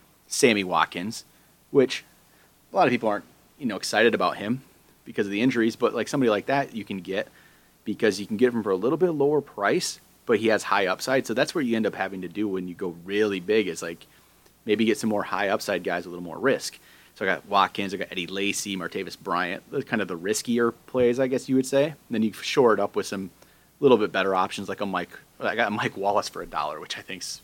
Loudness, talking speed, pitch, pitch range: -25 LUFS, 250 wpm, 105 Hz, 95-125 Hz